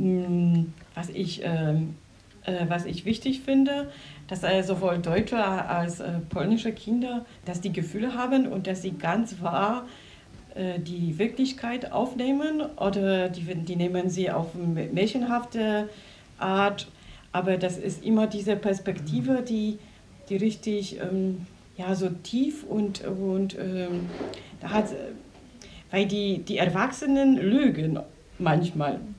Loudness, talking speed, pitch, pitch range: -27 LUFS, 125 wpm, 195 Hz, 175-220 Hz